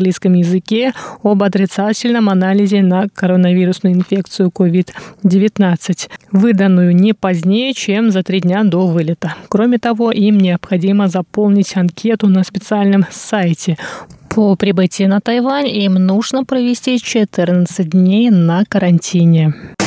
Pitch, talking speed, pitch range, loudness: 195 Hz, 120 wpm, 185-210 Hz, -13 LUFS